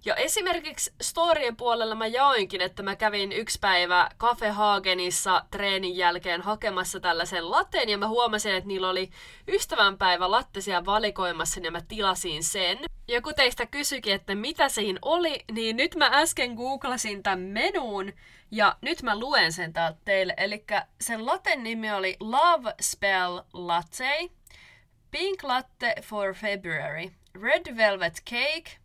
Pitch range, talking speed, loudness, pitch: 185-260 Hz, 145 wpm, -26 LUFS, 210 Hz